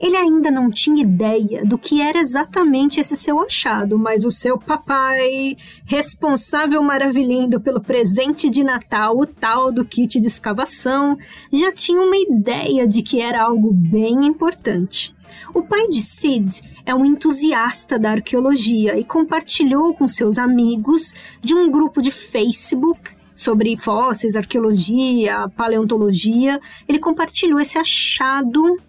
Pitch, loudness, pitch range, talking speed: 265 Hz, -17 LUFS, 230-305 Hz, 135 wpm